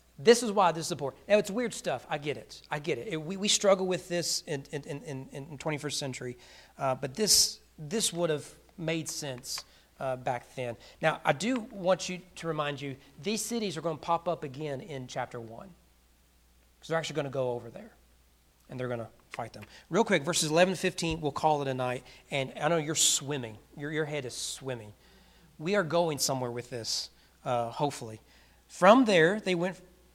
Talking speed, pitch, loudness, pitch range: 210 wpm, 150 Hz, -30 LUFS, 125-175 Hz